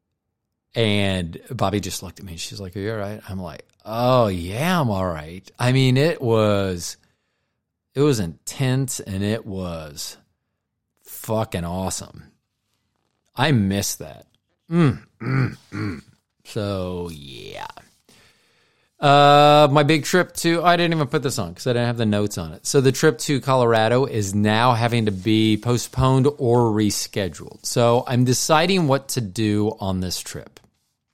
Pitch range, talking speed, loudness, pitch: 100-130 Hz, 155 wpm, -20 LUFS, 115 Hz